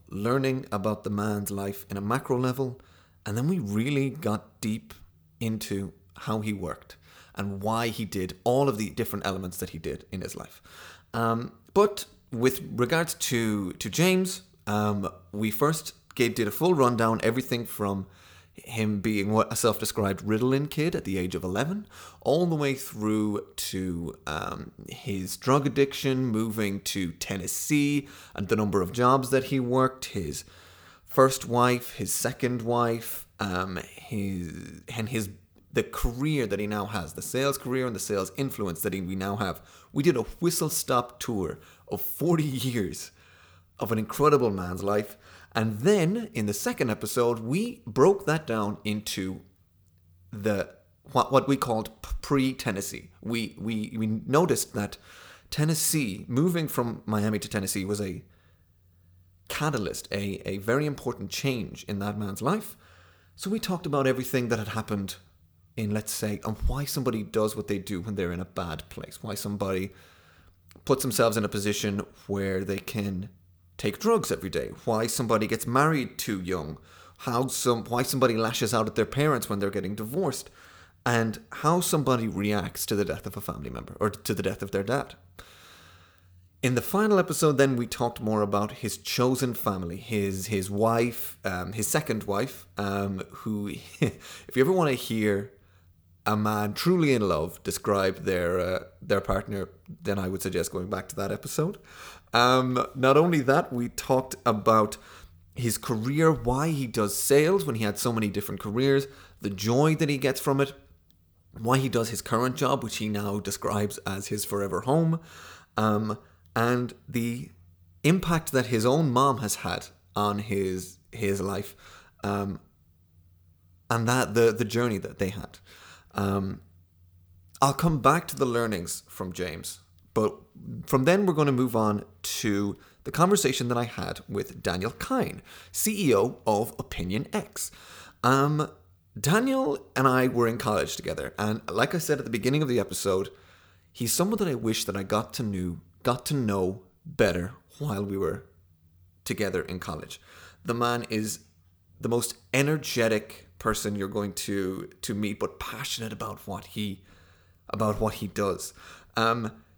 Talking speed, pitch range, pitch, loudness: 165 wpm, 95-130 Hz, 105 Hz, -28 LUFS